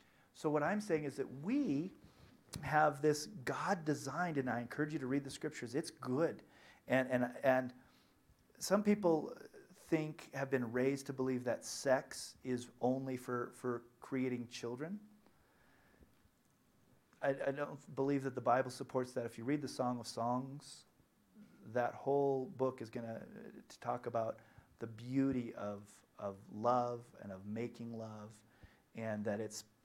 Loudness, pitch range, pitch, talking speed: -39 LUFS, 120-145 Hz, 130 Hz, 155 wpm